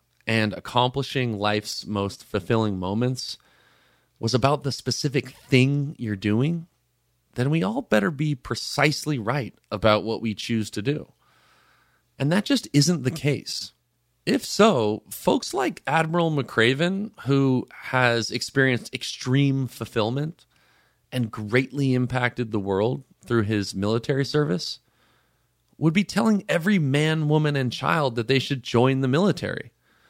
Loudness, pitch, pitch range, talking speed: -24 LUFS, 130 Hz, 115-145 Hz, 130 wpm